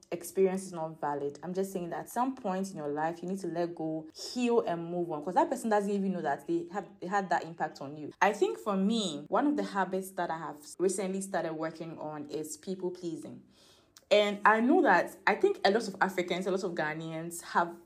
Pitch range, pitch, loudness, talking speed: 160-200 Hz, 180 Hz, -31 LUFS, 240 wpm